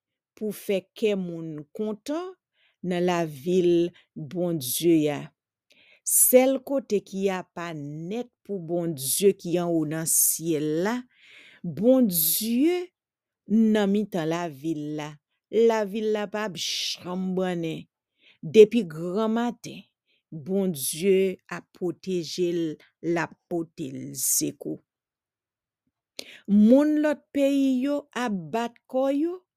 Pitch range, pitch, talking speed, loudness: 165-225 Hz, 185 Hz, 115 wpm, -25 LUFS